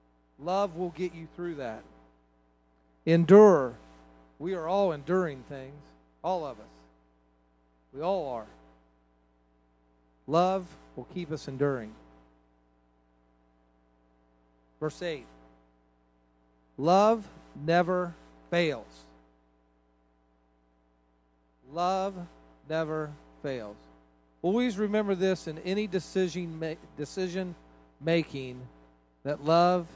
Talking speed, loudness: 80 wpm, -29 LUFS